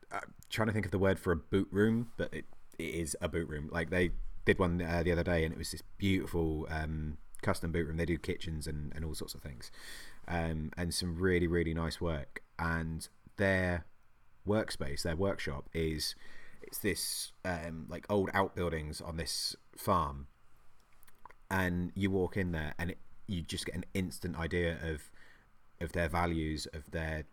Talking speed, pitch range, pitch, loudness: 185 wpm, 80-95 Hz, 85 Hz, -35 LUFS